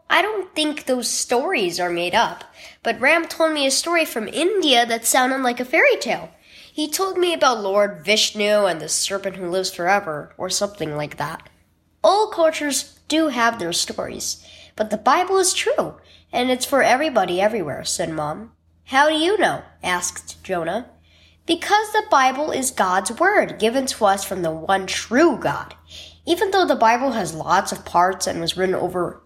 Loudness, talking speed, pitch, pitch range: -20 LUFS, 180 wpm, 240 Hz, 190-320 Hz